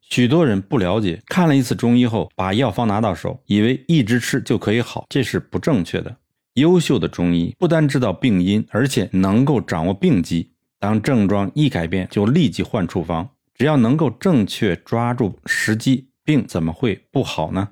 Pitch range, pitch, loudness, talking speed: 95-135 Hz, 110 Hz, -19 LUFS, 280 characters per minute